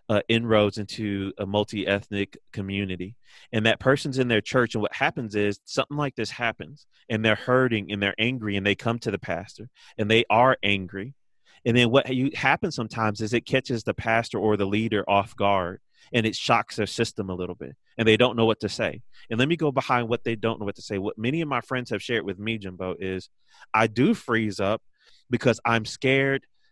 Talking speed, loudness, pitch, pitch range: 220 wpm, -25 LUFS, 110 Hz, 100-125 Hz